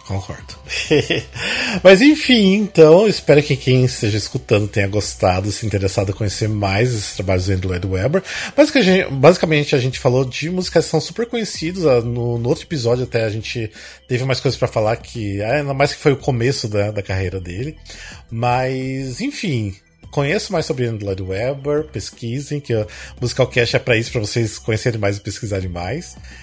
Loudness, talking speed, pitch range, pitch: -17 LUFS, 175 wpm, 105-150 Hz, 120 Hz